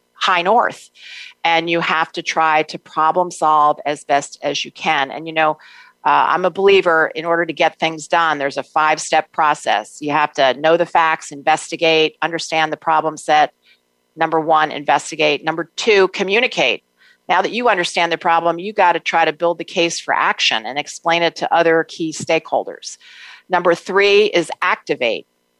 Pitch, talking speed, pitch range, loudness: 165 Hz, 180 wpm, 155-170 Hz, -16 LUFS